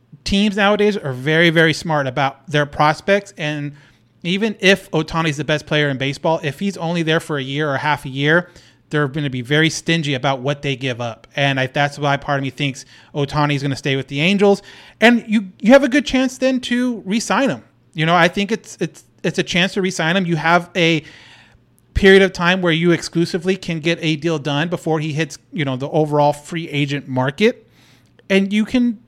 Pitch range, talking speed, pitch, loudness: 145-190 Hz, 225 wpm, 160 Hz, -17 LUFS